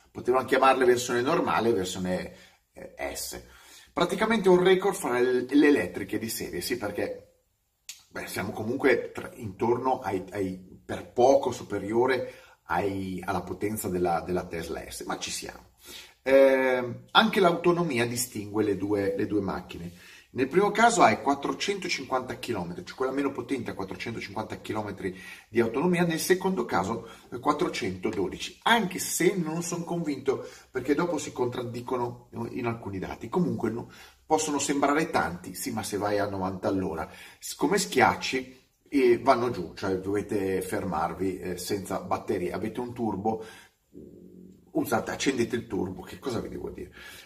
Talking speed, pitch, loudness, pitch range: 145 wpm, 120 Hz, -27 LUFS, 100-150 Hz